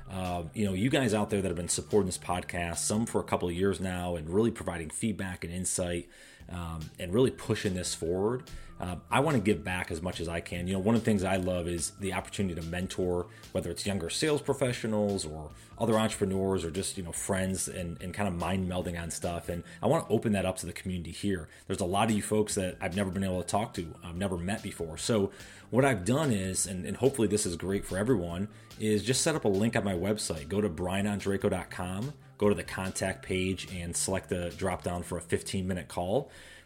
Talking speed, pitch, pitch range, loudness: 235 wpm, 95 Hz, 90-105 Hz, -31 LUFS